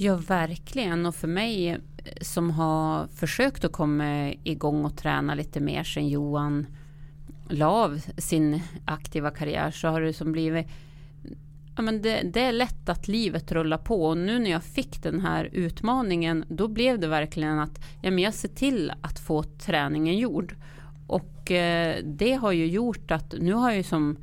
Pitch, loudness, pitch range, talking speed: 160 Hz, -27 LUFS, 150-185 Hz, 170 wpm